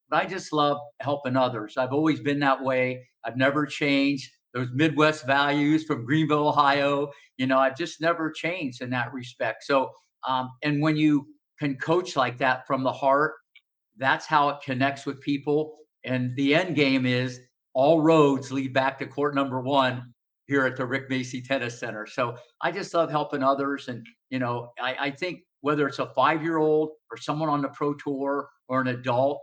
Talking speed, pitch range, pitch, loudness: 190 wpm, 130-150 Hz, 140 Hz, -25 LUFS